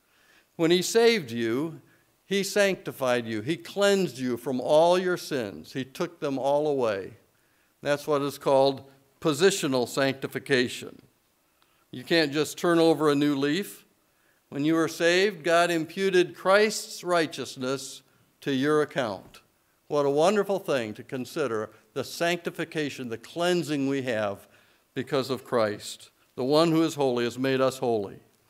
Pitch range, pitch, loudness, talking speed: 135-175 Hz, 150 Hz, -26 LUFS, 145 wpm